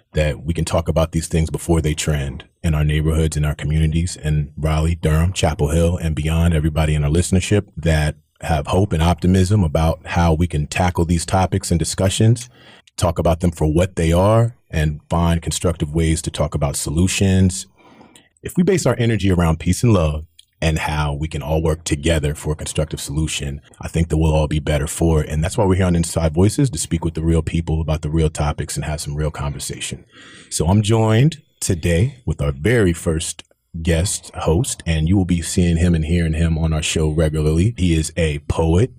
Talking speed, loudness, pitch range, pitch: 210 wpm, -19 LUFS, 80-90 Hz, 80 Hz